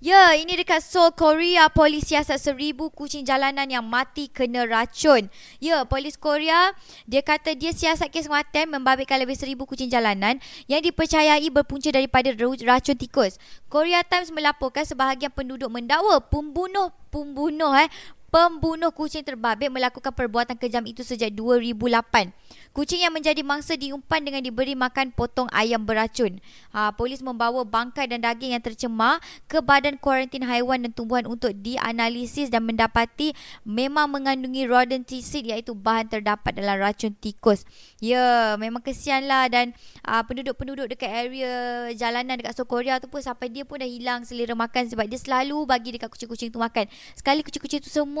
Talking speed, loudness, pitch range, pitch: 155 wpm, -23 LUFS, 240-295 Hz, 265 Hz